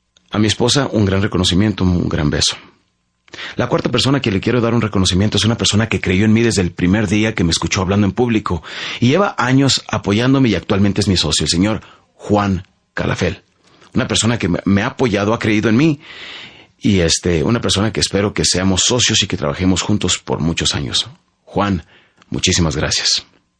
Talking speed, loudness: 195 wpm, -16 LUFS